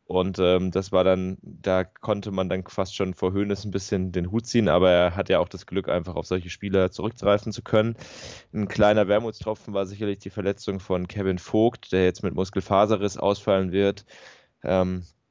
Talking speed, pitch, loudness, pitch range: 190 wpm, 100 Hz, -24 LUFS, 95-105 Hz